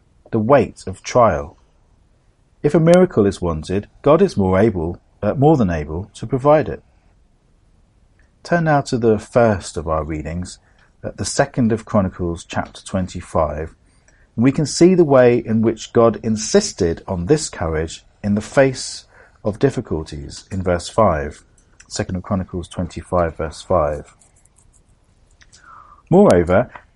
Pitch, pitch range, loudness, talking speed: 100 Hz, 85-115 Hz, -18 LUFS, 140 wpm